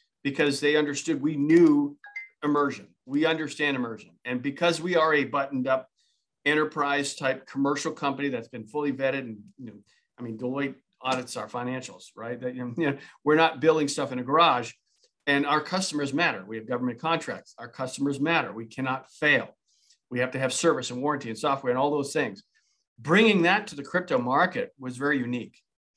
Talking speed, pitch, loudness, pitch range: 185 wpm, 140 Hz, -26 LUFS, 130-160 Hz